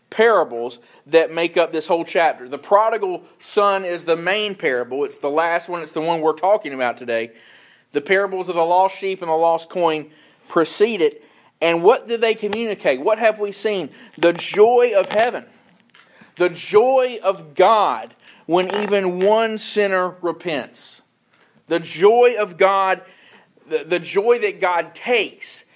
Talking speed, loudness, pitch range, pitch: 160 wpm, -19 LUFS, 165-215 Hz, 185 Hz